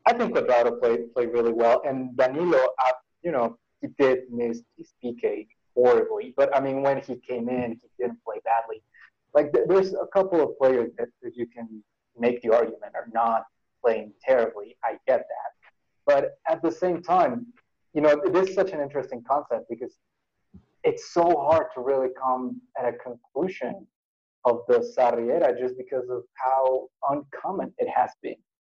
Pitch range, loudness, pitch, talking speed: 125-190 Hz, -25 LUFS, 135 Hz, 175 wpm